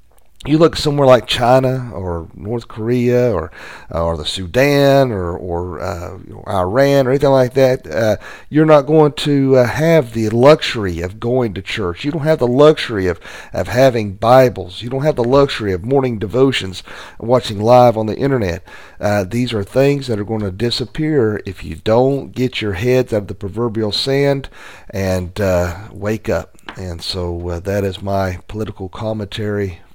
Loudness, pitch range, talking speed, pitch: -16 LUFS, 95-130 Hz, 175 wpm, 110 Hz